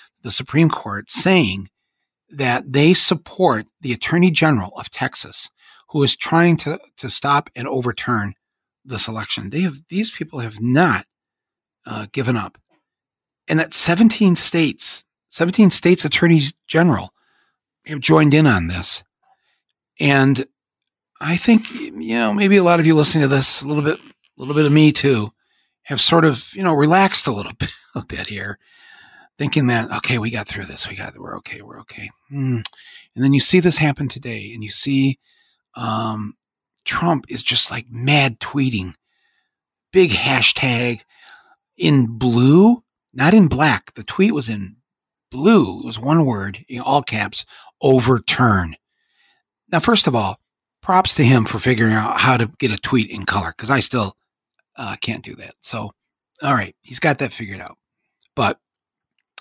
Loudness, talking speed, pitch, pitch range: -16 LUFS, 160 wpm, 135 Hz, 115-165 Hz